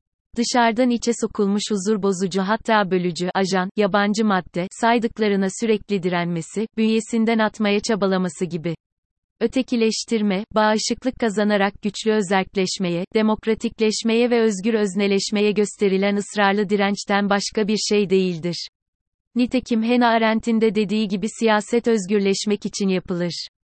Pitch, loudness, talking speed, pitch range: 210 Hz, -21 LUFS, 110 wpm, 195-225 Hz